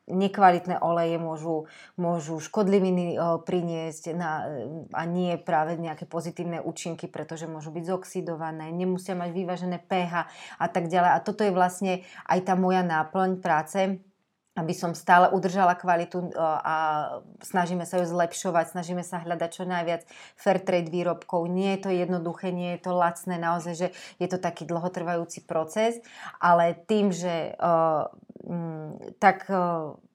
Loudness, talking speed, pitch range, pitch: -27 LUFS, 145 wpm, 170-185 Hz, 175 Hz